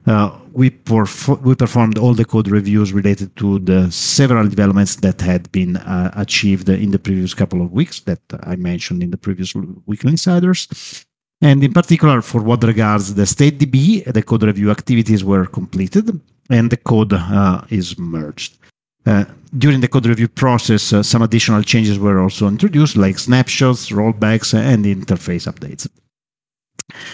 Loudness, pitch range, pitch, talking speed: -15 LUFS, 100-130 Hz, 110 Hz, 160 wpm